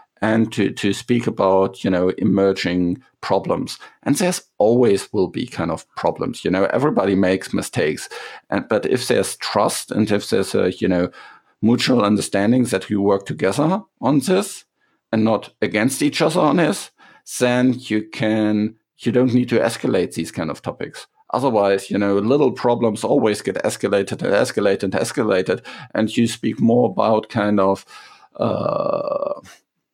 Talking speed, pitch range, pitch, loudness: 160 wpm, 100-125 Hz, 110 Hz, -19 LUFS